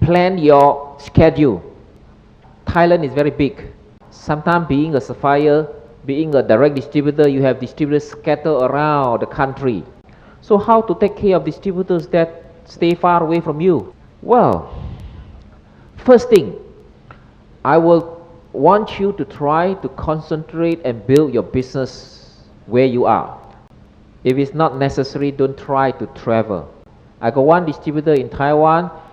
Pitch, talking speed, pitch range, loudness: 150 Hz, 140 wpm, 135-165 Hz, -16 LUFS